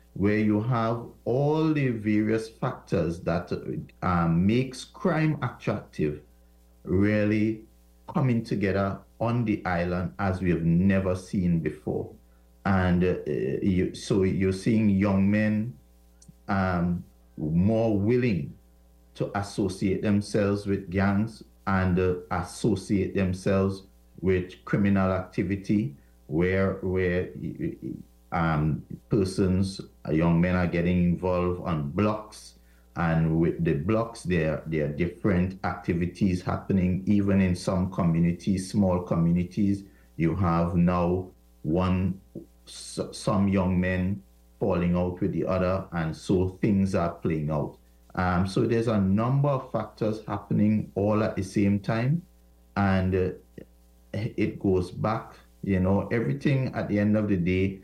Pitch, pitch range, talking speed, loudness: 95 Hz, 85-105 Hz, 125 wpm, -26 LUFS